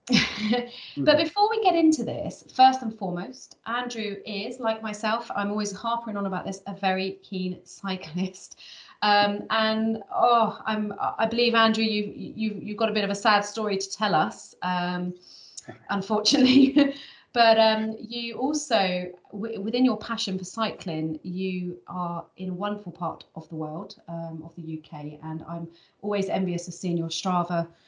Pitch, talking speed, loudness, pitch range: 205 Hz, 165 wpm, -25 LUFS, 180-225 Hz